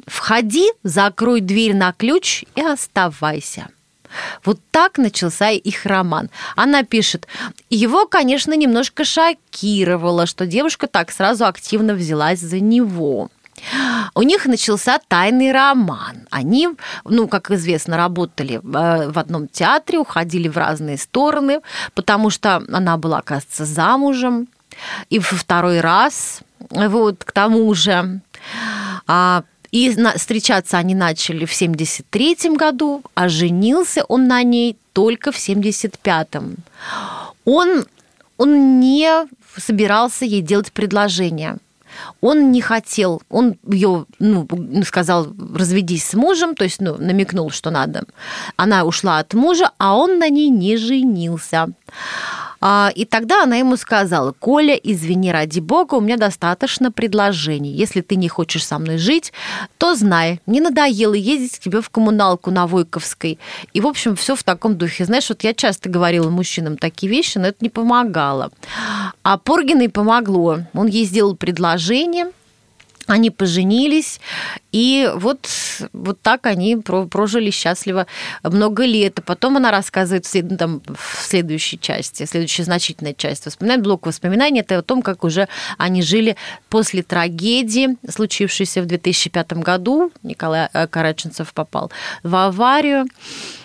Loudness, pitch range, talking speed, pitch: -16 LUFS, 175-245 Hz, 130 wpm, 205 Hz